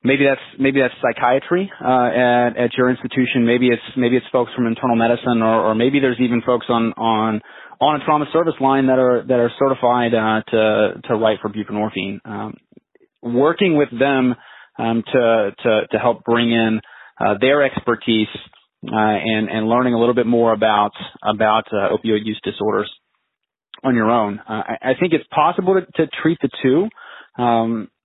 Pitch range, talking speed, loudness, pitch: 110-130 Hz, 180 wpm, -18 LUFS, 120 Hz